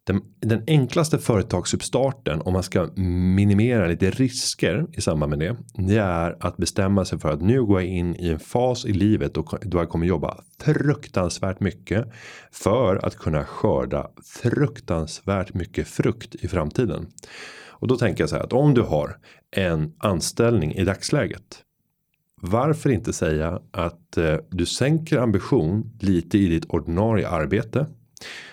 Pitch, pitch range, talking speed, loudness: 100 Hz, 85-120 Hz, 150 wpm, -23 LUFS